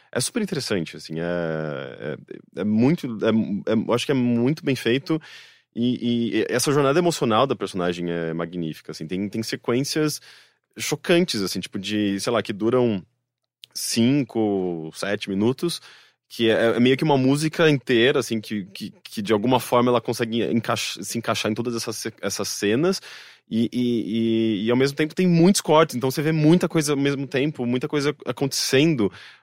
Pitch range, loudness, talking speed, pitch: 110-140 Hz, -22 LUFS, 175 wpm, 120 Hz